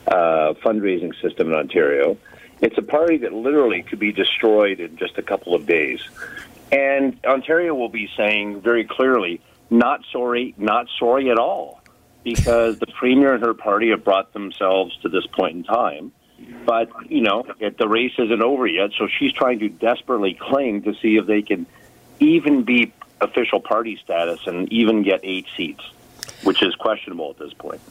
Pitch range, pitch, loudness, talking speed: 105-135 Hz, 115 Hz, -19 LUFS, 175 wpm